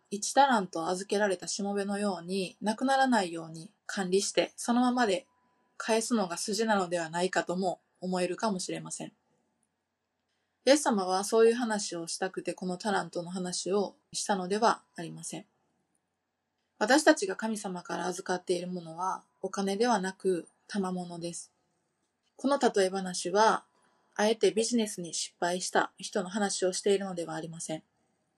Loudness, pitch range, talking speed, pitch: -30 LUFS, 175-215 Hz, 325 characters per minute, 190 Hz